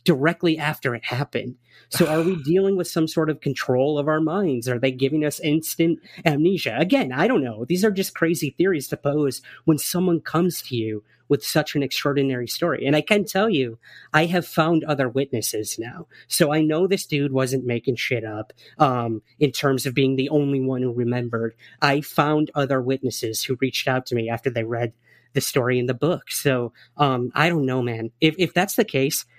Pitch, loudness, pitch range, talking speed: 140 Hz, -22 LUFS, 125-160 Hz, 205 wpm